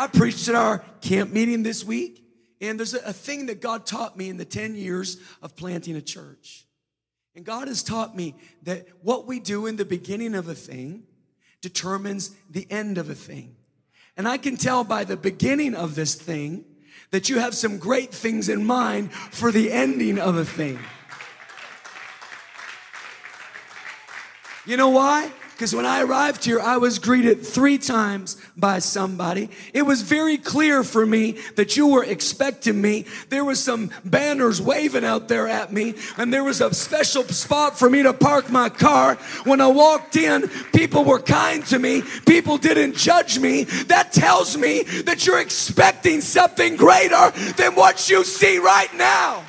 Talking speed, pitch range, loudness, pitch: 175 wpm, 190-265 Hz, -19 LUFS, 225 Hz